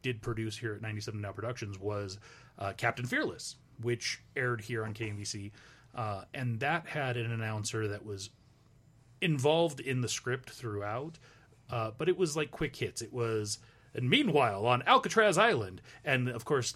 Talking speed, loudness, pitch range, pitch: 165 wpm, -33 LUFS, 110-130 Hz, 120 Hz